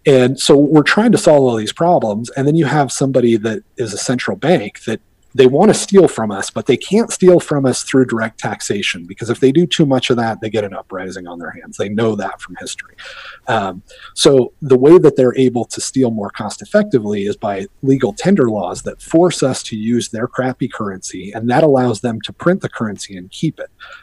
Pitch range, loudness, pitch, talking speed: 110-150 Hz, -14 LUFS, 130 Hz, 225 wpm